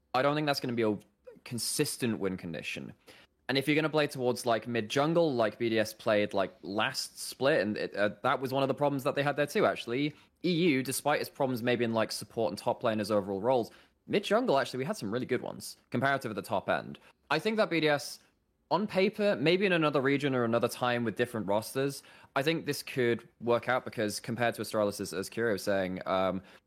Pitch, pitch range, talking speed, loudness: 125 Hz, 110-145 Hz, 230 wpm, -31 LUFS